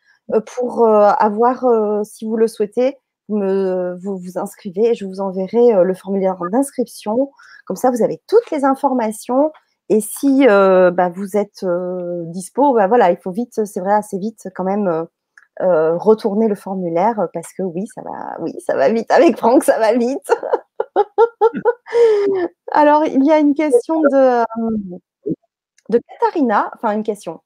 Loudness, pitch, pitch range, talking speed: -16 LUFS, 225 Hz, 195-275 Hz, 165 wpm